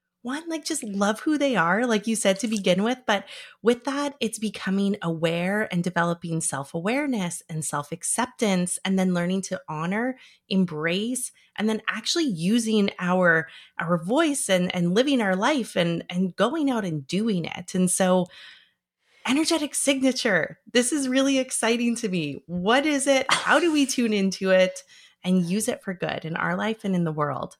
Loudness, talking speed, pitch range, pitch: -24 LUFS, 175 wpm, 180-250 Hz, 205 Hz